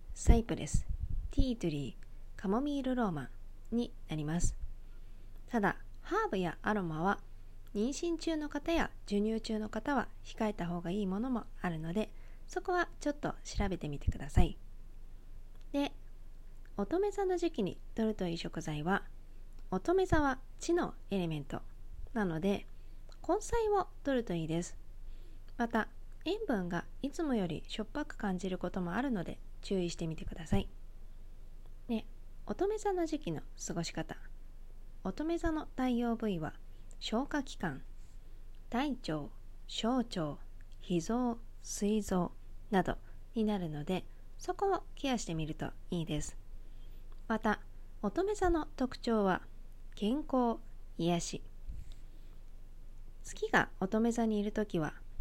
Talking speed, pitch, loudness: 250 characters per minute, 185 Hz, -36 LUFS